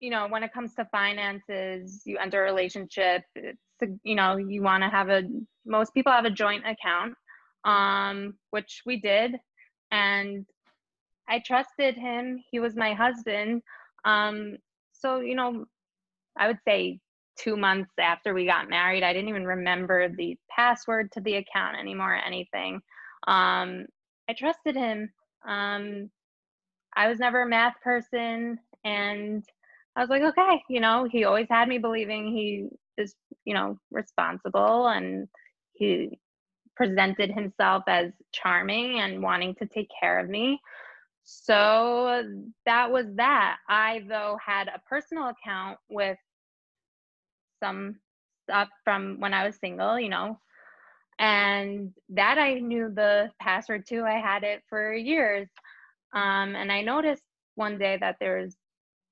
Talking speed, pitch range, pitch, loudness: 145 wpm, 195-235 Hz, 210 Hz, -26 LUFS